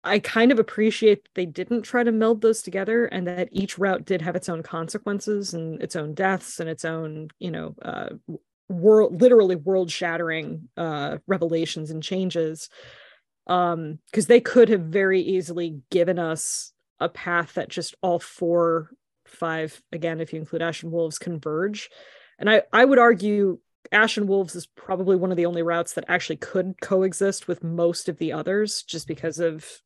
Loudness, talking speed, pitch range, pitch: -23 LUFS, 175 wpm, 165-205 Hz, 180 Hz